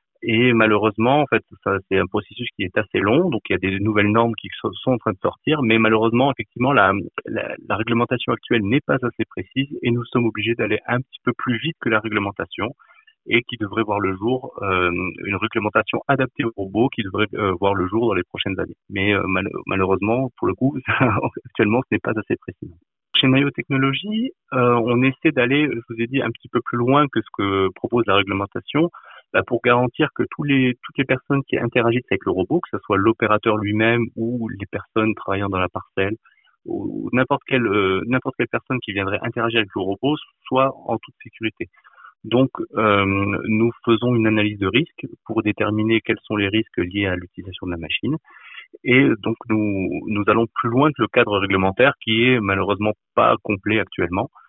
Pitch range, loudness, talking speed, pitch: 100-125 Hz, -20 LUFS, 205 wpm, 115 Hz